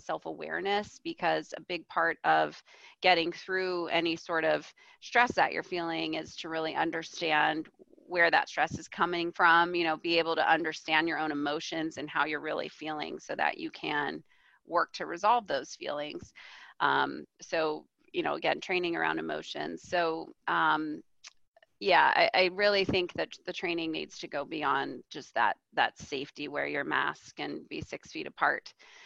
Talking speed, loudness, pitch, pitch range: 170 wpm, -30 LUFS, 170 Hz, 160-200 Hz